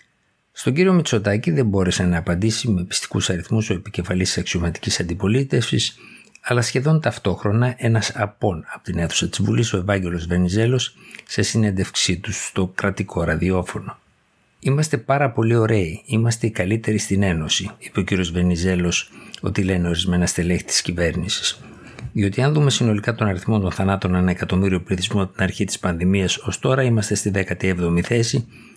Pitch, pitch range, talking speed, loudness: 100 Hz, 90-115 Hz, 155 wpm, -20 LUFS